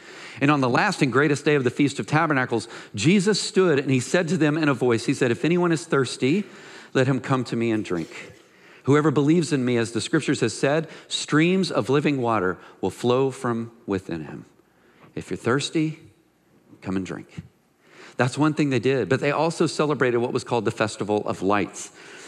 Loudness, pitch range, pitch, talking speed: -23 LUFS, 120-155 Hz, 135 Hz, 200 wpm